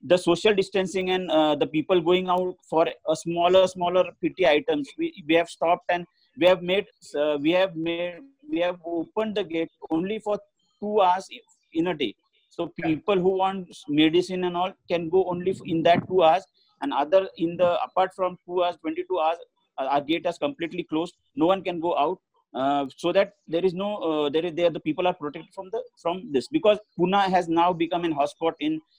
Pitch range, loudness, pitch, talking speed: 165-190 Hz, -25 LUFS, 175 Hz, 205 wpm